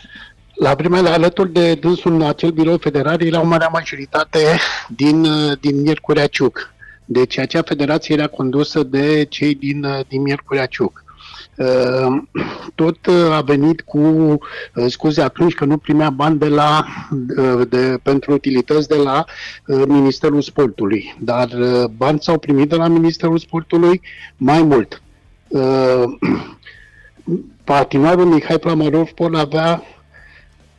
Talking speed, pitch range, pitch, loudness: 120 wpm, 135-165 Hz, 150 Hz, -15 LUFS